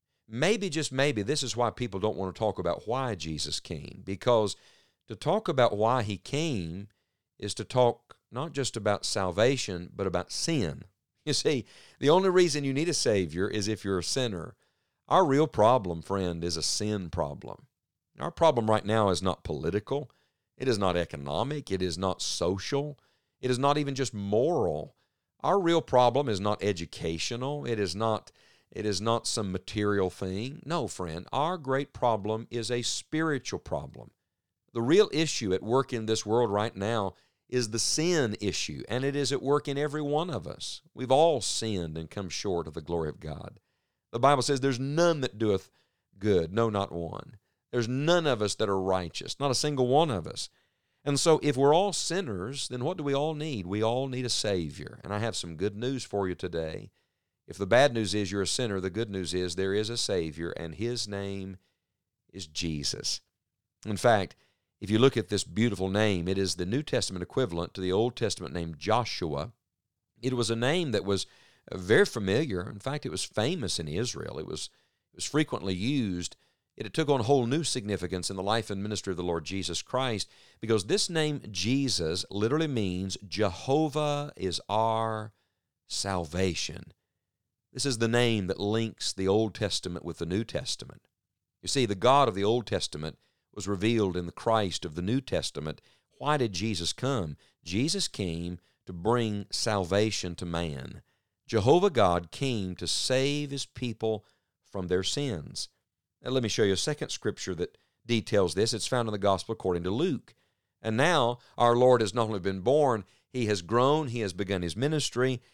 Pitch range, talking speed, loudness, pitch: 95-130 Hz, 190 wpm, -29 LUFS, 110 Hz